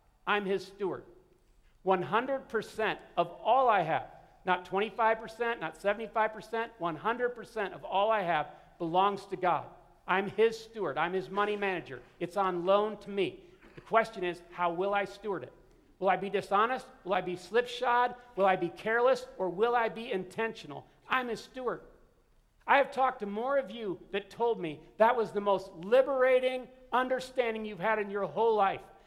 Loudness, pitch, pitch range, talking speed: -31 LUFS, 210 Hz, 190-235 Hz, 170 wpm